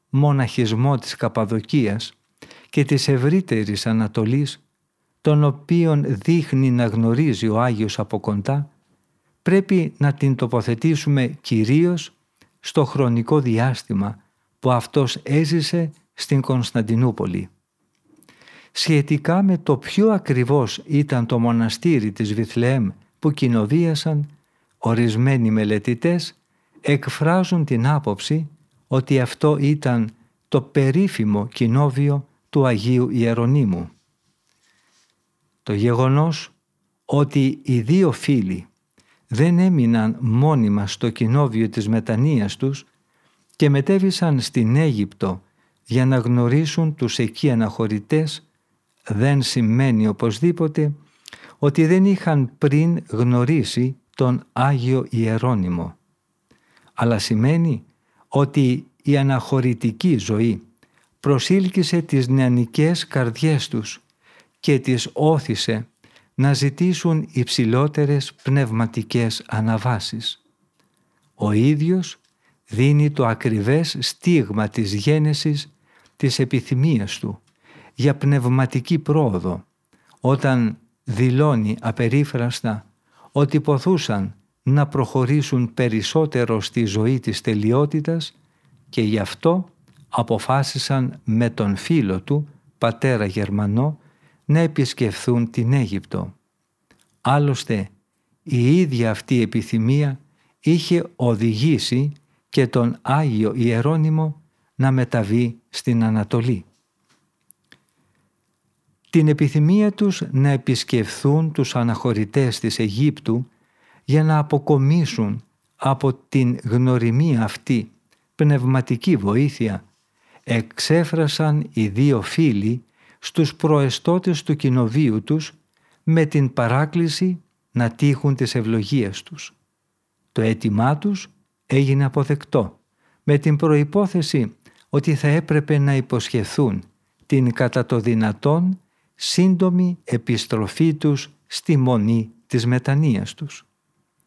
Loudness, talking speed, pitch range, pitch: -20 LUFS, 95 wpm, 115-150 Hz, 135 Hz